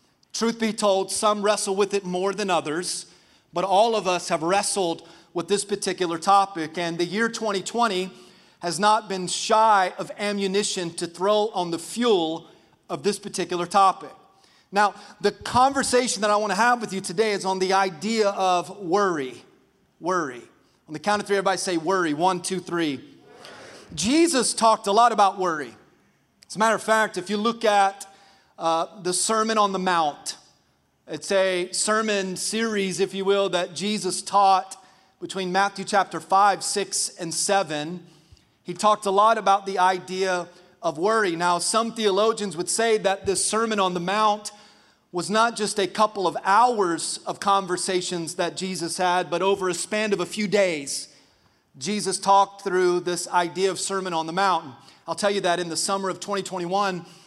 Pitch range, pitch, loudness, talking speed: 180-210 Hz, 195 Hz, -23 LUFS, 175 wpm